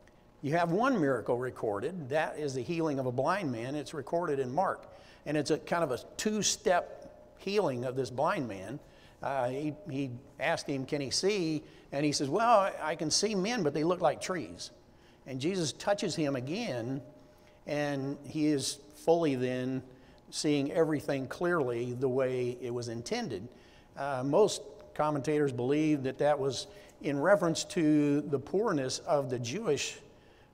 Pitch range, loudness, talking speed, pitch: 135-165 Hz, -32 LUFS, 165 wpm, 145 Hz